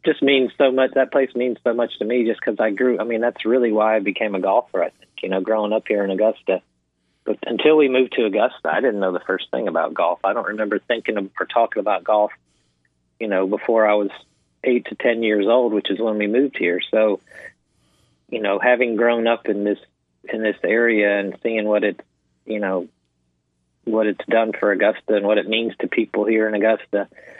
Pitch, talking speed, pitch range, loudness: 110 Hz, 225 wpm, 100-120 Hz, -20 LUFS